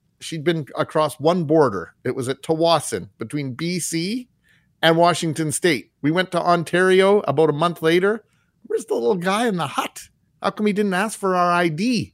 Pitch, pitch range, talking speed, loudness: 170 Hz, 160-185 Hz, 185 wpm, -20 LUFS